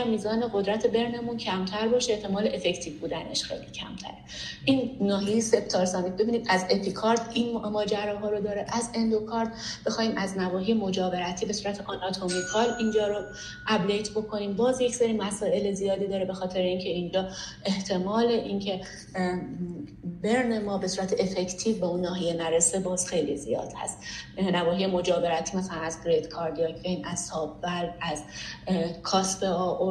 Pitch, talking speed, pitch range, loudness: 195 Hz, 140 wpm, 180-220 Hz, -28 LUFS